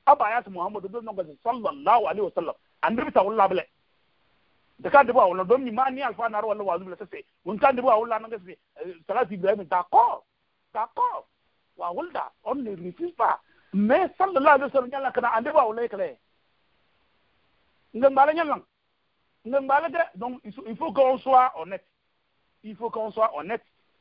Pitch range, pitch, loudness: 205-275 Hz, 240 Hz, -24 LUFS